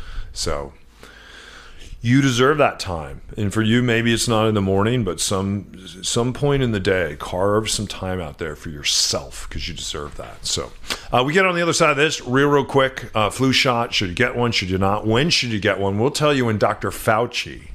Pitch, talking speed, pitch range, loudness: 110 Hz, 225 wpm, 100-125 Hz, -19 LUFS